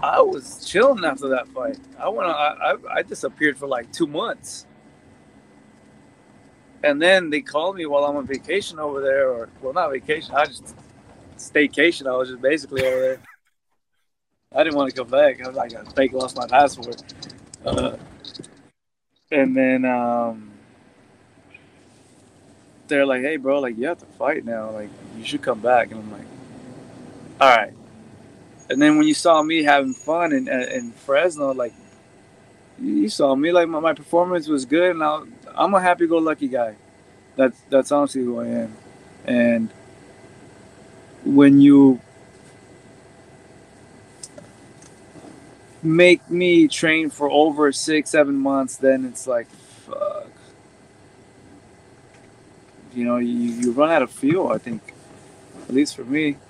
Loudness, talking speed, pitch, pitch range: -20 LUFS, 150 wpm, 135 Hz, 120-160 Hz